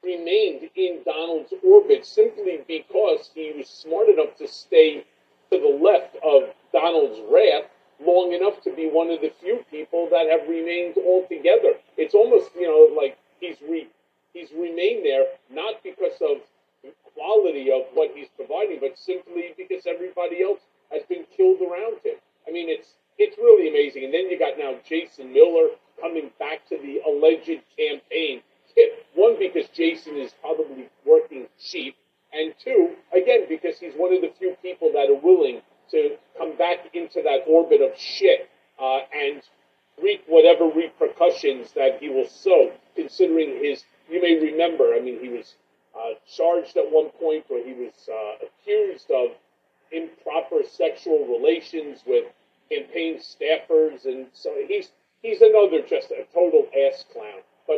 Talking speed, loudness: 160 wpm, -21 LUFS